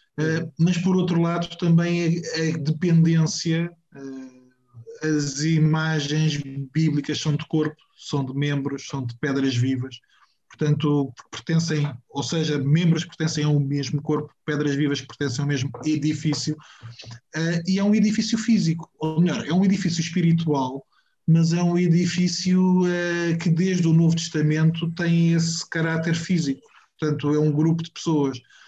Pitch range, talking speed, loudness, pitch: 145-170 Hz, 145 wpm, -23 LUFS, 155 Hz